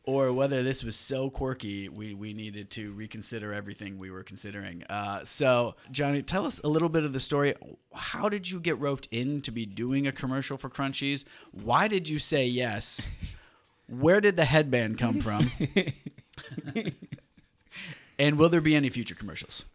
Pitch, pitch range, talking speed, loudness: 130 Hz, 105-145 Hz, 175 wpm, -28 LUFS